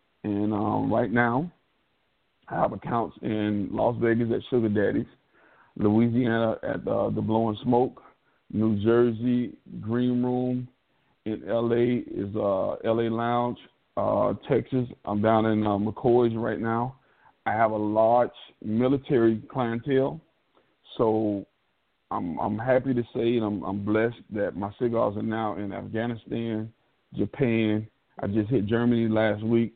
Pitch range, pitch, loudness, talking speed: 110-120 Hz, 115 Hz, -26 LUFS, 135 wpm